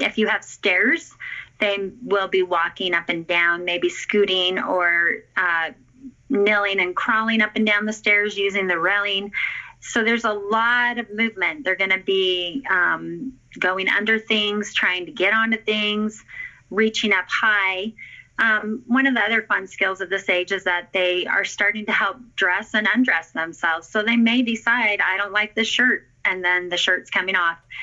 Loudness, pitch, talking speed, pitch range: -20 LUFS, 205 Hz, 180 wpm, 185-225 Hz